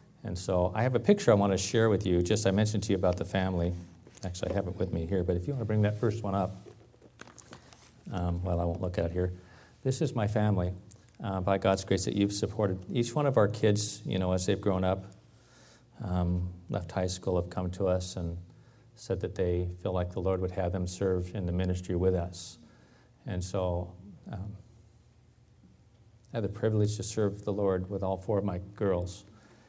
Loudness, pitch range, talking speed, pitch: -31 LUFS, 90-110 Hz, 220 wpm, 95 Hz